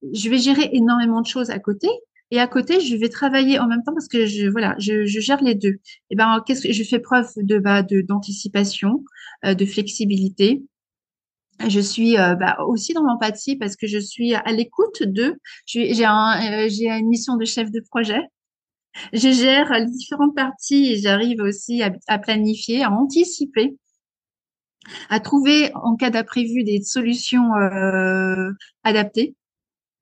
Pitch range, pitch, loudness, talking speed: 210-260 Hz, 230 Hz, -19 LUFS, 175 wpm